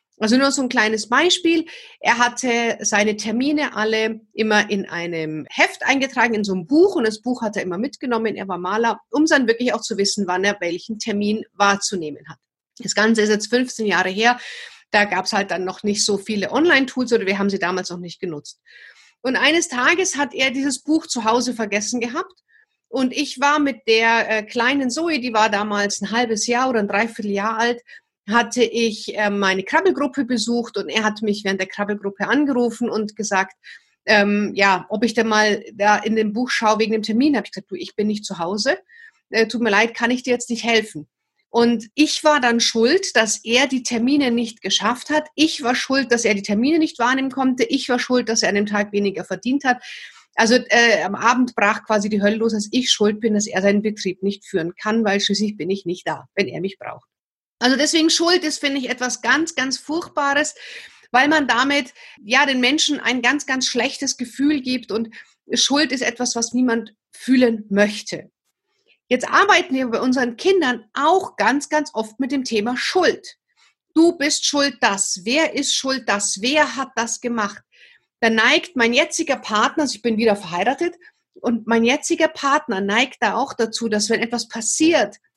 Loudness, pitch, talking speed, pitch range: -19 LUFS, 235 Hz, 200 wpm, 210-275 Hz